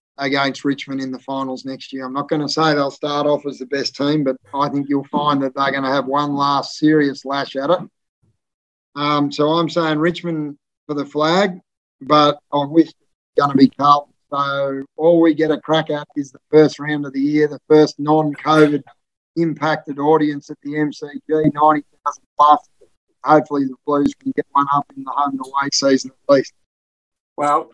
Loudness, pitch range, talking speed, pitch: -18 LUFS, 140-150 Hz, 195 wpm, 145 Hz